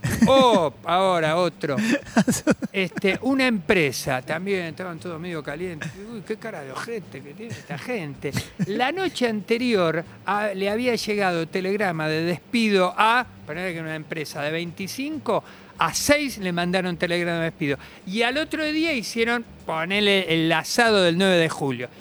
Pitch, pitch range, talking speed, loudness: 190 Hz, 165-230 Hz, 155 wpm, -23 LUFS